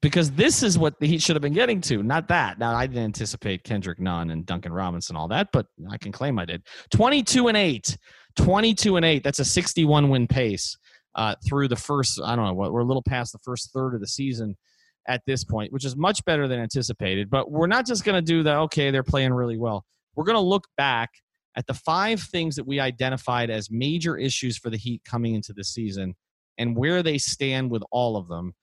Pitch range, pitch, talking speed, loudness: 110-155 Hz, 130 Hz, 235 wpm, -24 LUFS